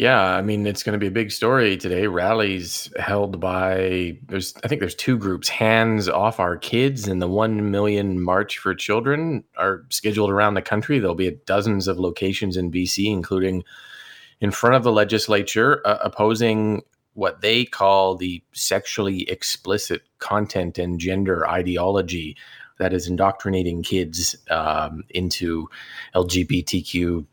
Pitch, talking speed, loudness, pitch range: 95 Hz, 150 wpm, -21 LUFS, 90-105 Hz